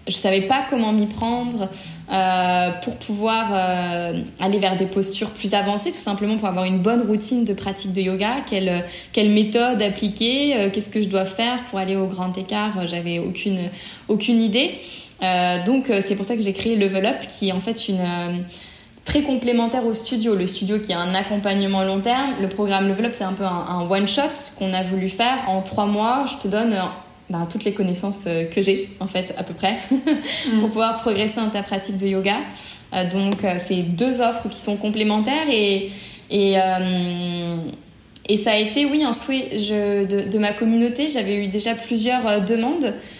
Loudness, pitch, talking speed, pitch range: -21 LUFS, 205 Hz, 195 wpm, 190-230 Hz